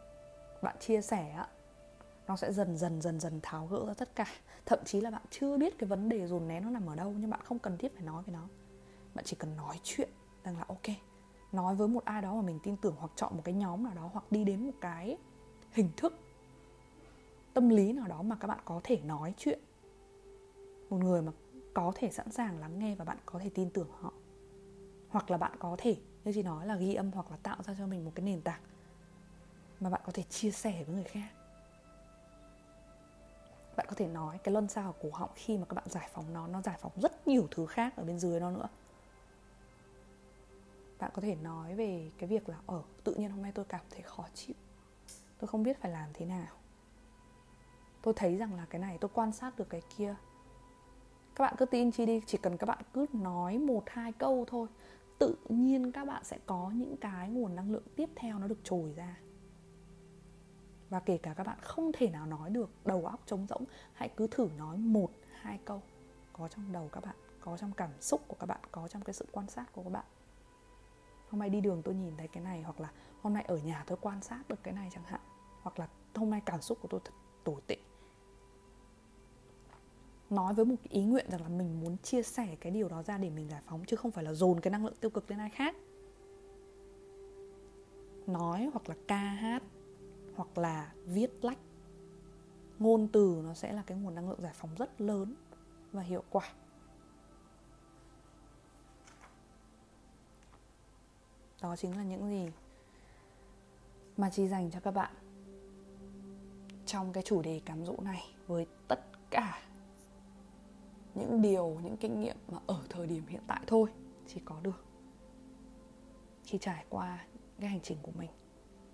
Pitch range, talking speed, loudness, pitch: 175-220 Hz, 205 wpm, -37 LUFS, 195 Hz